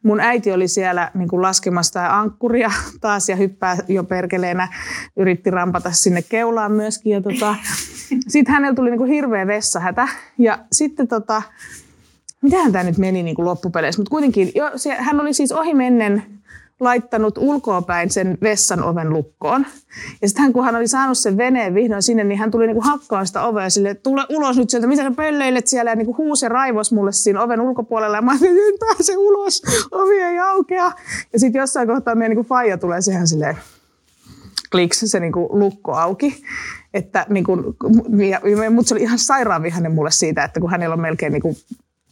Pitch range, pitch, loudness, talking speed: 190-260 Hz, 220 Hz, -17 LUFS, 185 wpm